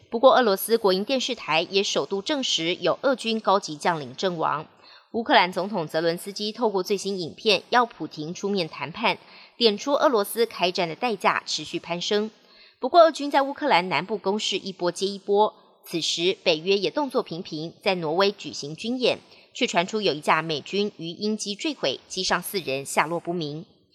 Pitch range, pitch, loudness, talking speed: 170-225 Hz, 195 Hz, -24 LUFS, 285 characters per minute